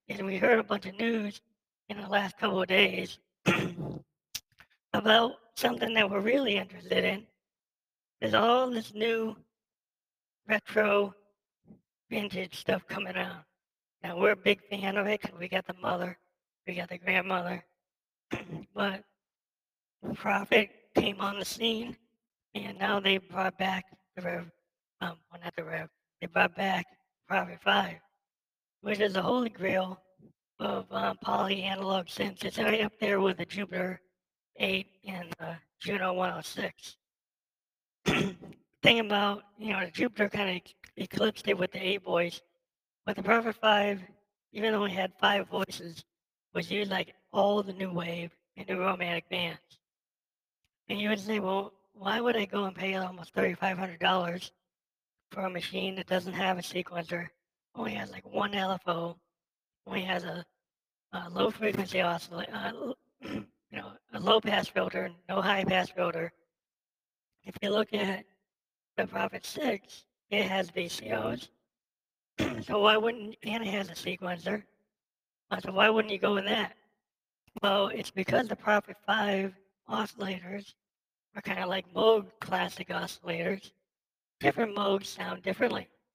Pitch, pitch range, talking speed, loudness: 195 Hz, 180-210 Hz, 145 wpm, -30 LUFS